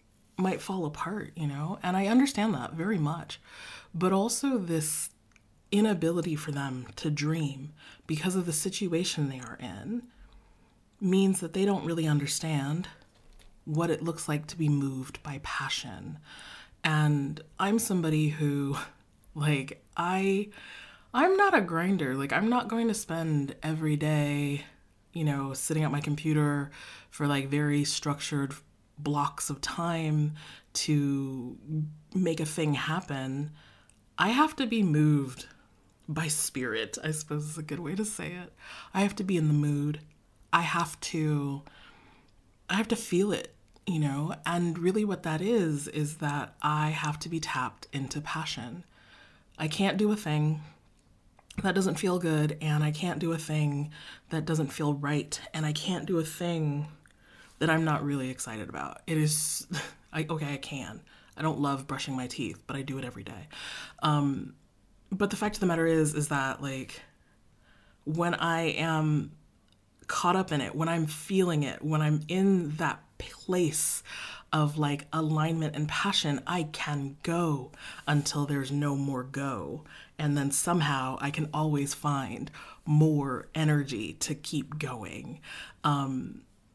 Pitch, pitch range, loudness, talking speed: 150 Hz, 140-170 Hz, -30 LUFS, 155 wpm